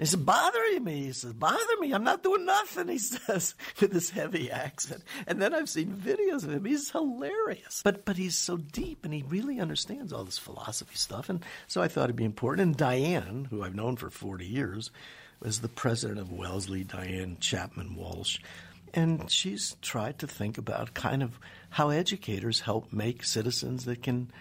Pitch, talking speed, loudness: 140 Hz, 190 wpm, -31 LUFS